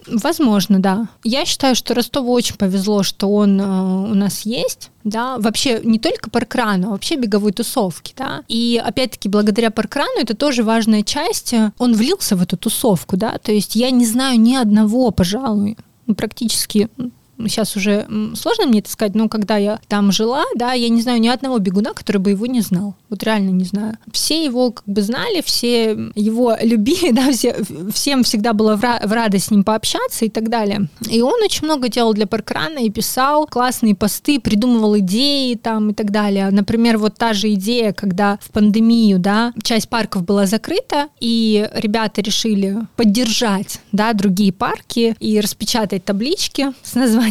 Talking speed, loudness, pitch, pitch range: 175 wpm, -16 LUFS, 225 Hz, 210-245 Hz